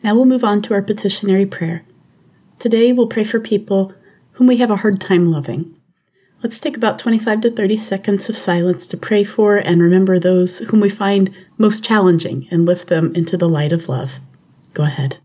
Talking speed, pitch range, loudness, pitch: 195 wpm, 175-215 Hz, -15 LUFS, 195 Hz